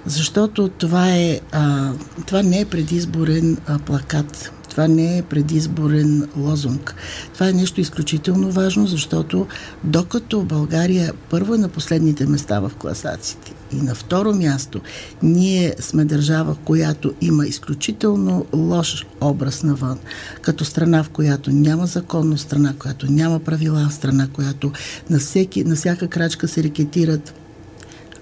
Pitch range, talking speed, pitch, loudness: 145-170 Hz, 135 wpm, 155 Hz, -19 LUFS